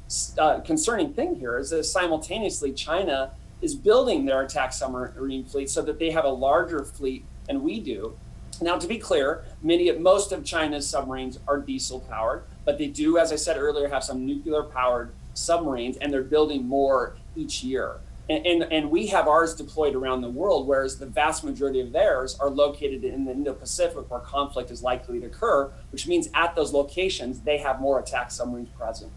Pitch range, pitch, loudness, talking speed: 130-165 Hz, 145 Hz, -25 LUFS, 185 wpm